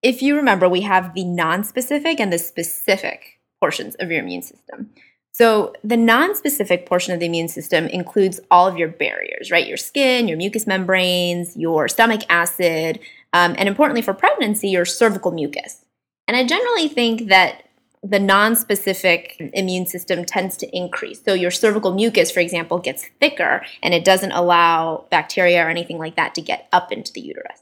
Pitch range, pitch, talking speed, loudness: 175-225 Hz, 190 Hz, 175 wpm, -18 LUFS